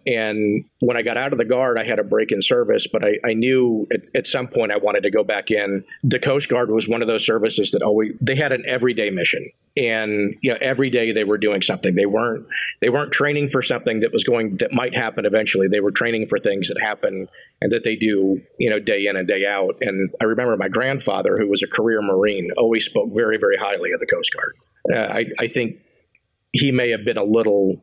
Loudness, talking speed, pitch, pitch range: -19 LUFS, 245 wpm, 115 Hz, 105-135 Hz